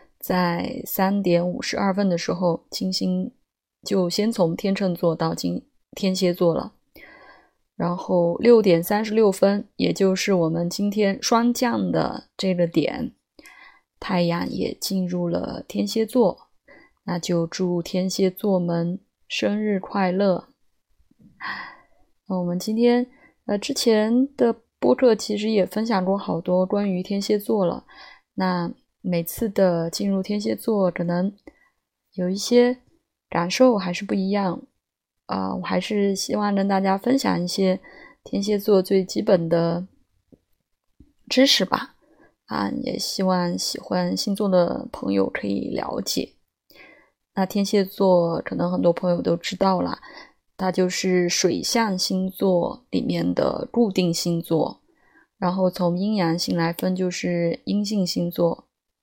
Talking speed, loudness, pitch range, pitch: 195 characters per minute, -22 LUFS, 175-210 Hz, 190 Hz